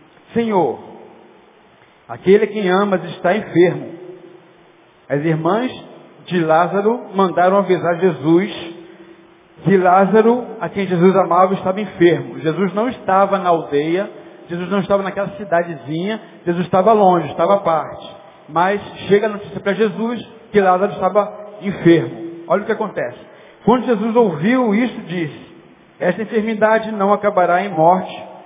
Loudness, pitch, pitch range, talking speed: -17 LUFS, 190 Hz, 170-205 Hz, 135 wpm